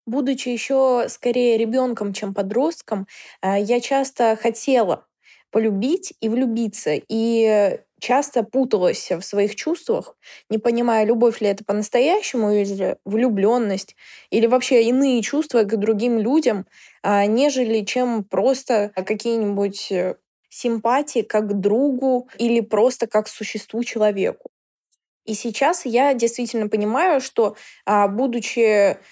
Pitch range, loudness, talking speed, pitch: 210-250 Hz, -20 LUFS, 110 wpm, 230 Hz